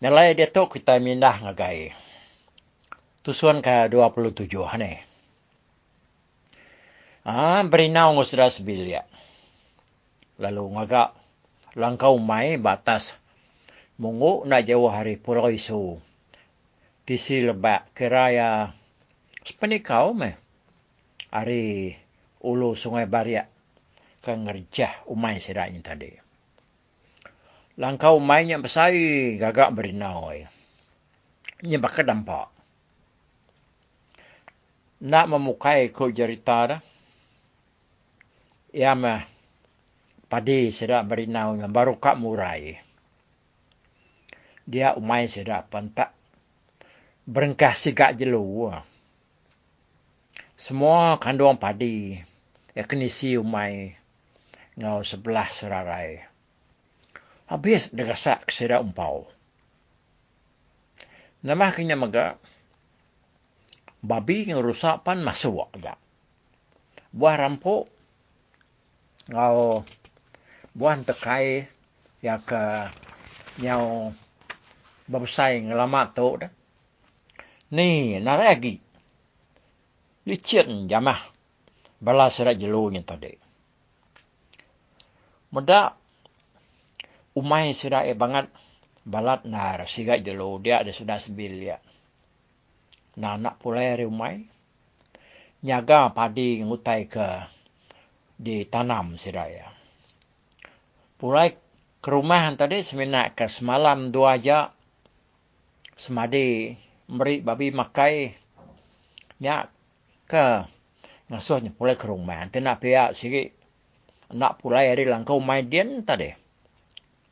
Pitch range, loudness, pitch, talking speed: 105-135 Hz, -23 LUFS, 120 Hz, 85 wpm